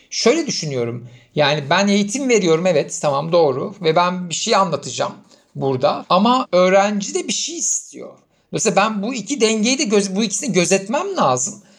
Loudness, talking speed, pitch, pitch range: -18 LUFS, 160 wpm, 195 Hz, 170-220 Hz